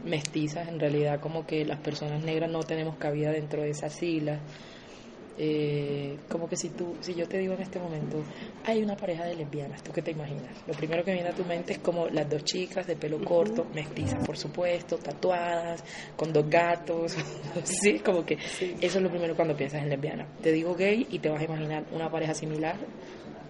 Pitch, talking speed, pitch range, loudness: 165 Hz, 205 wpm, 150-175 Hz, -30 LUFS